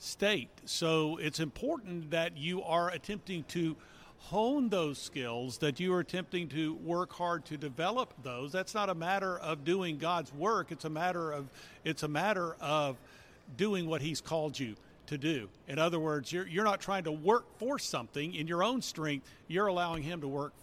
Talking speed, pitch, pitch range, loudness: 190 wpm, 165 Hz, 150-185 Hz, -35 LUFS